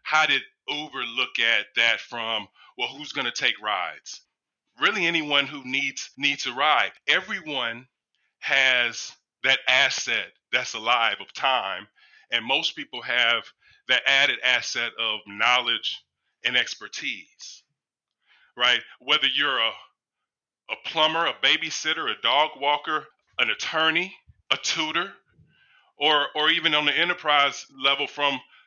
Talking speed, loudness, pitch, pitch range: 130 wpm, -23 LUFS, 145 Hz, 135-160 Hz